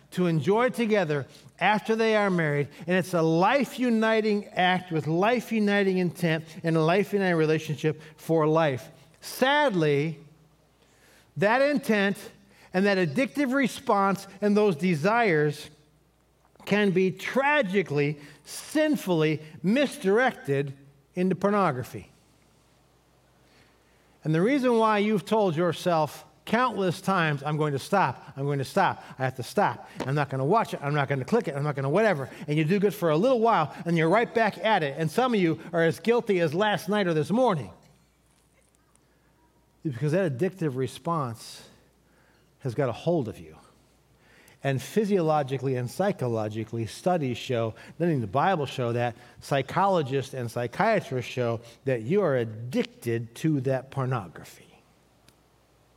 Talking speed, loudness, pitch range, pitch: 150 wpm, -26 LUFS, 140-200 Hz, 165 Hz